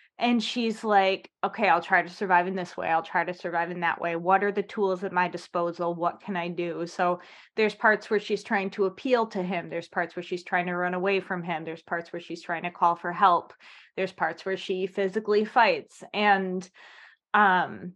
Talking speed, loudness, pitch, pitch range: 220 wpm, -27 LUFS, 185 Hz, 175-200 Hz